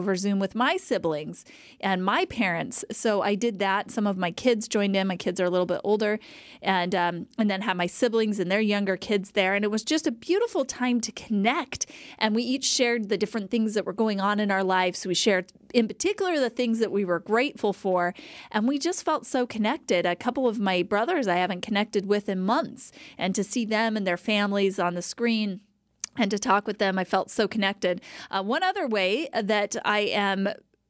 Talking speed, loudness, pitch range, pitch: 220 wpm, -26 LUFS, 195-235 Hz, 210 Hz